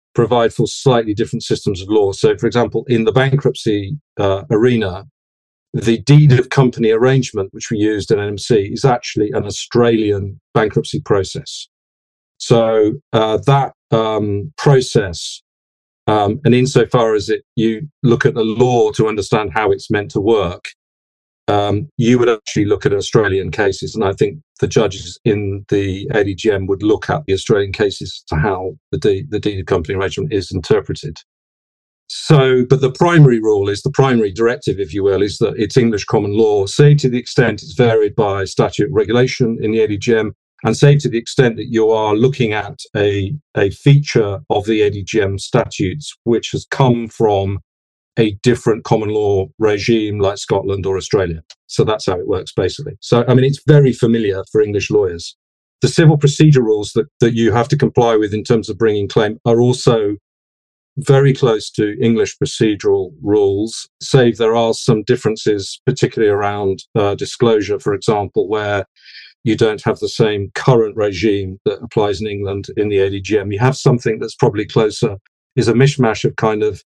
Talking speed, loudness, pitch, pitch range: 175 wpm, -15 LUFS, 110 Hz, 100-130 Hz